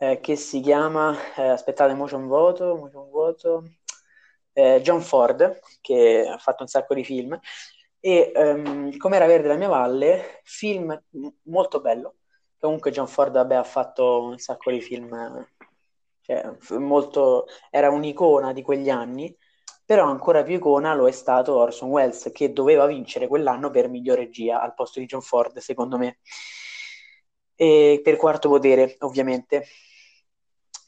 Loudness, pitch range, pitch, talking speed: -21 LUFS, 130-190 Hz, 145 Hz, 145 wpm